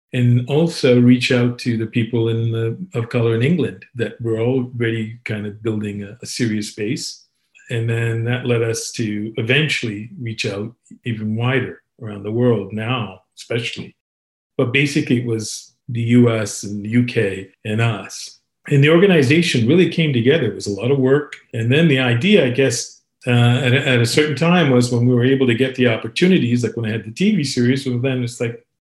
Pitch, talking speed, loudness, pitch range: 120 Hz, 195 wpm, -18 LUFS, 115-130 Hz